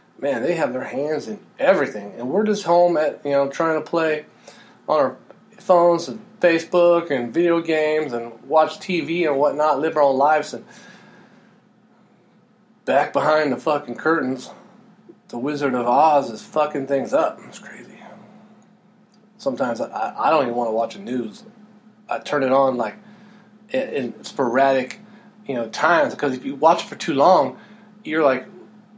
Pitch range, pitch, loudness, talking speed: 140-215 Hz, 170 Hz, -20 LUFS, 165 wpm